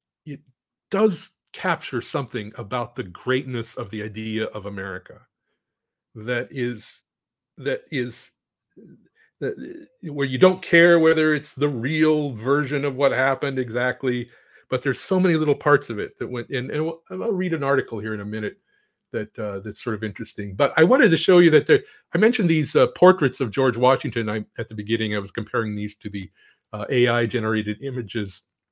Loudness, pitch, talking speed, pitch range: -22 LUFS, 130 Hz, 170 wpm, 110-150 Hz